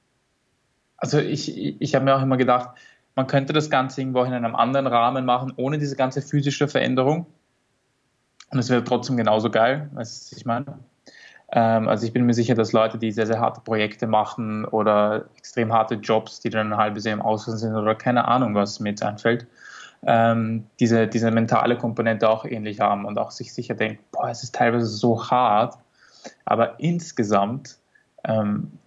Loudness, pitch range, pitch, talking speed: -22 LUFS, 110-130 Hz, 120 Hz, 180 wpm